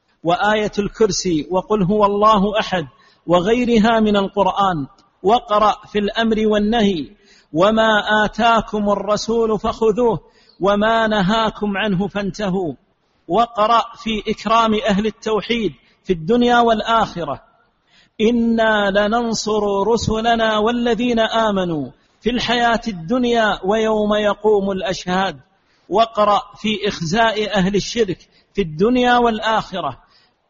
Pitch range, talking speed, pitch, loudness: 200-225 Hz, 95 wpm, 215 Hz, -17 LUFS